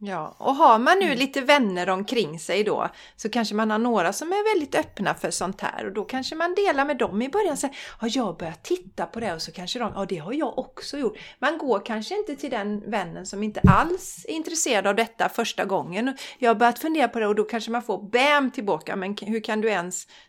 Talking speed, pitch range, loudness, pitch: 245 wpm, 205-285 Hz, -24 LUFS, 230 Hz